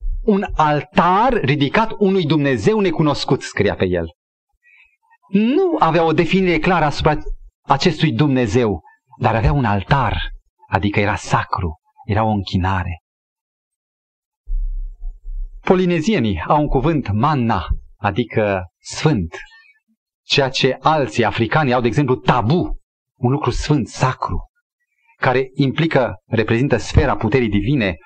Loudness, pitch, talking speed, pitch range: -17 LUFS, 145 Hz, 110 wpm, 120-190 Hz